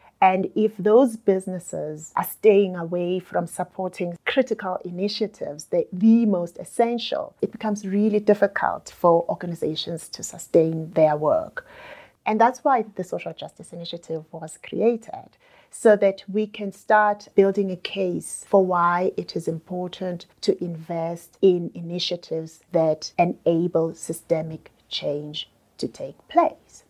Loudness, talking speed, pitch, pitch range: -23 LUFS, 130 wpm, 185 Hz, 170-215 Hz